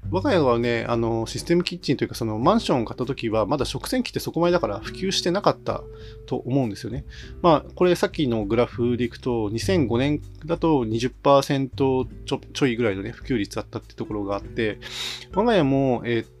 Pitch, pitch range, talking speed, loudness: 120 Hz, 110-140 Hz, 405 characters per minute, -23 LUFS